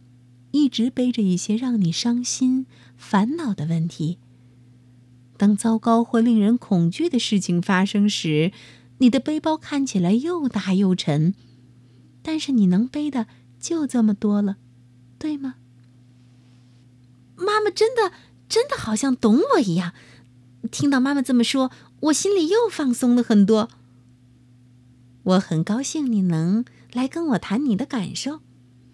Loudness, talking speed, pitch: -21 LUFS, 195 characters per minute, 200 Hz